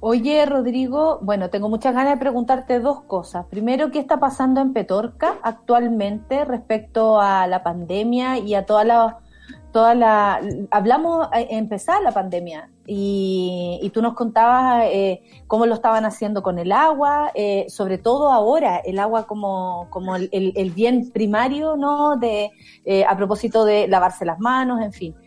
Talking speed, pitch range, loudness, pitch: 160 wpm, 200-255 Hz, -19 LUFS, 225 Hz